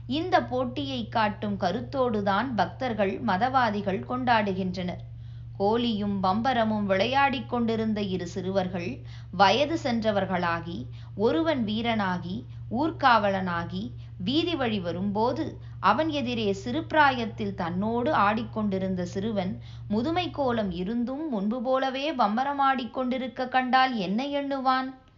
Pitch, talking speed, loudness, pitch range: 215 Hz, 85 wpm, -27 LUFS, 185-260 Hz